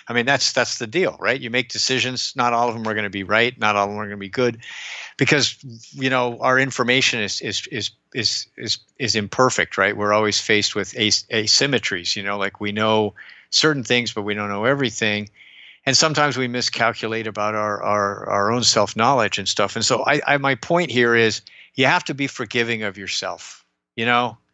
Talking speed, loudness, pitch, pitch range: 215 wpm, -20 LUFS, 115 Hz, 105-125 Hz